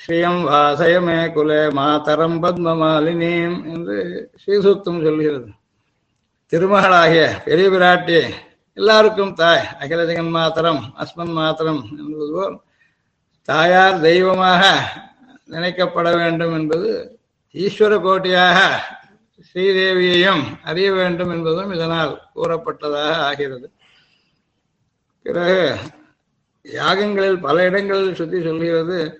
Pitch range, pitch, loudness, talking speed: 160-185 Hz, 170 Hz, -16 LUFS, 80 wpm